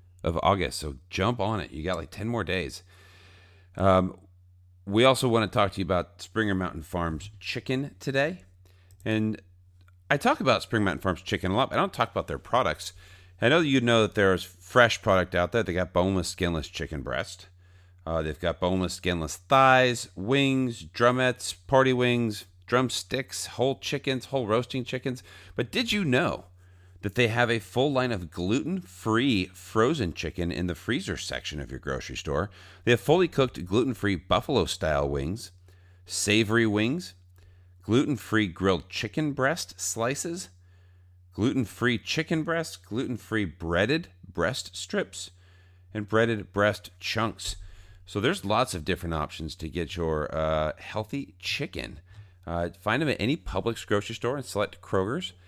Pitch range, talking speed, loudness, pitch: 90-115 Hz, 165 wpm, -27 LUFS, 95 Hz